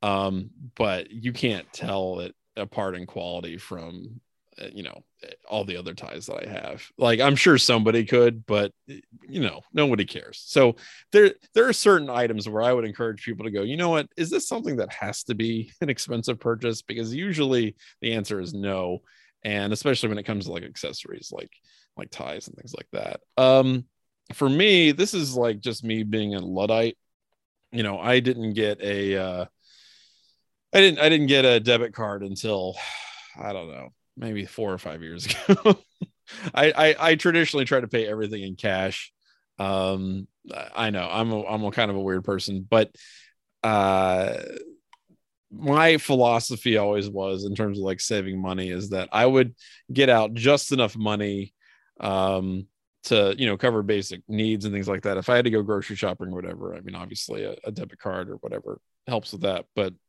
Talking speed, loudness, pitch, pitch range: 190 wpm, -23 LUFS, 110 Hz, 100-130 Hz